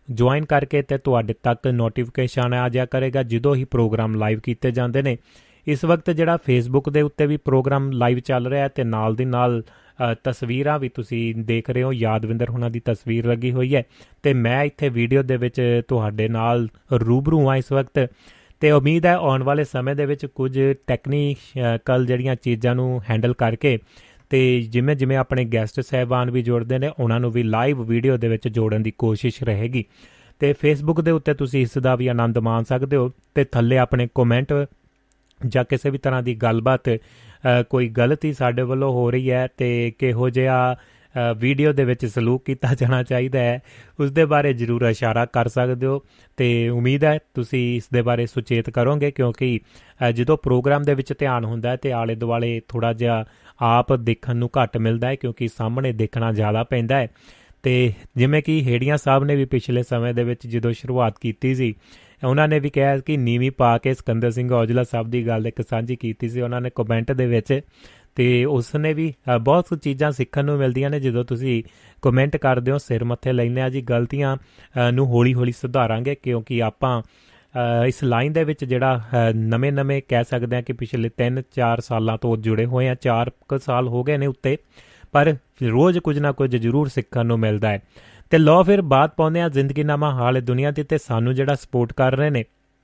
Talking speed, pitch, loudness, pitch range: 185 wpm, 125 Hz, -21 LUFS, 120-135 Hz